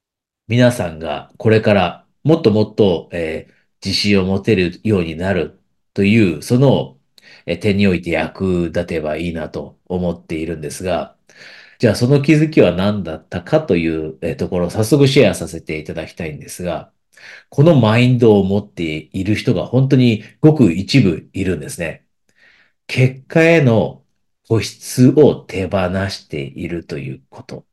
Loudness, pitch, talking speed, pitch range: -16 LUFS, 100 Hz, 295 characters per minute, 85-125 Hz